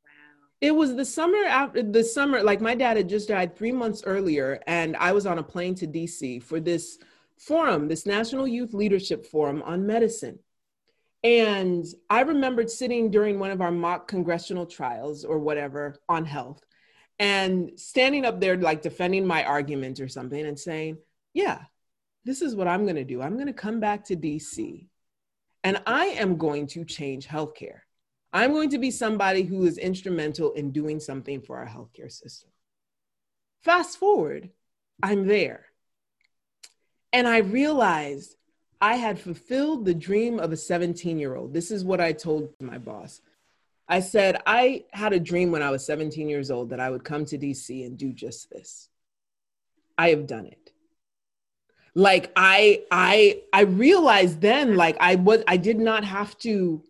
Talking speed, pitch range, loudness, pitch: 170 wpm, 155-230 Hz, -24 LUFS, 185 Hz